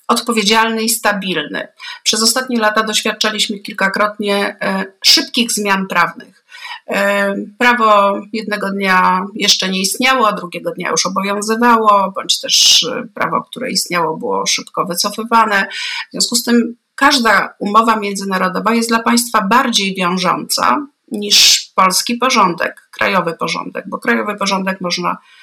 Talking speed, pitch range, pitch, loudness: 120 wpm, 195-235 Hz, 215 Hz, -13 LUFS